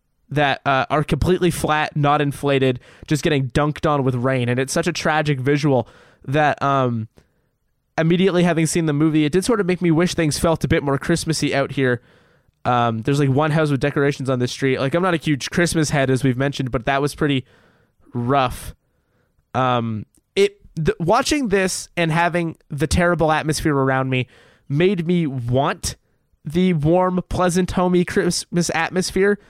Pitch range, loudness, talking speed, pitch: 135-170 Hz, -19 LUFS, 175 wpm, 150 Hz